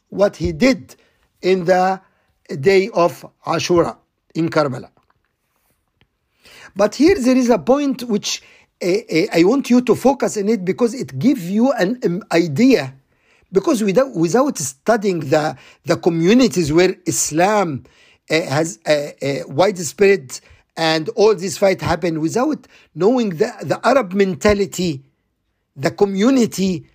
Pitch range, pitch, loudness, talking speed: 160-220 Hz, 185 Hz, -17 LUFS, 135 wpm